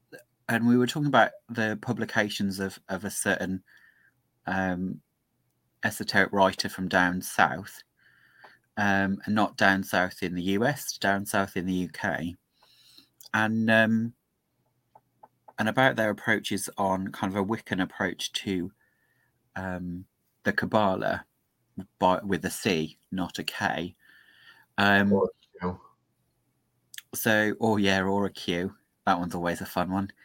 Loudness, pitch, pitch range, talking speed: -27 LUFS, 100 Hz, 95-110 Hz, 130 wpm